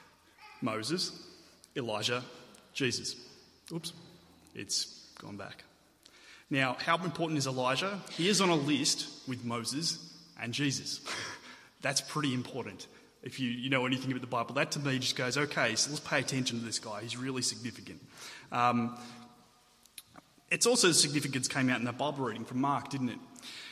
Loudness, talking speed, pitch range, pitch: -32 LUFS, 160 wpm, 120-155 Hz, 135 Hz